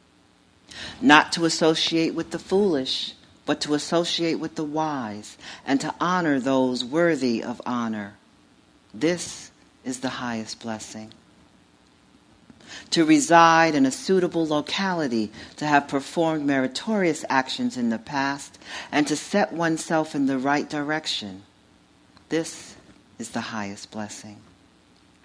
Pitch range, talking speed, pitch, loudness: 110-165 Hz, 120 wpm, 145 Hz, -23 LUFS